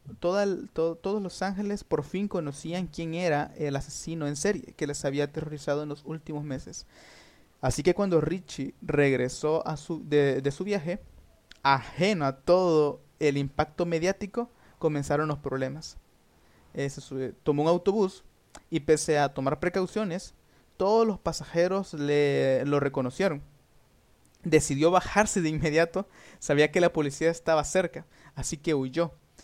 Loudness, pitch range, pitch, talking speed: -28 LUFS, 145-180 Hz, 155 Hz, 145 wpm